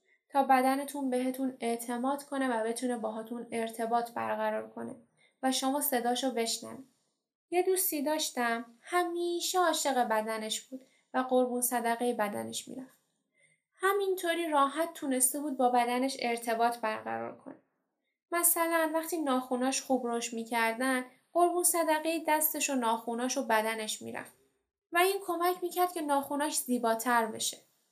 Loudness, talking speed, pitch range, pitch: -31 LUFS, 125 wpm, 235-310 Hz, 260 Hz